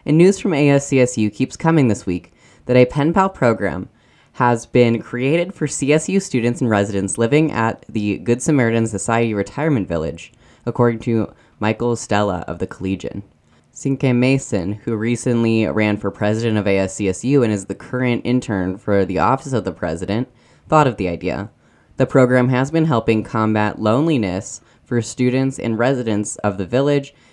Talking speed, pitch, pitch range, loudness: 160 wpm, 115 Hz, 100-130 Hz, -18 LUFS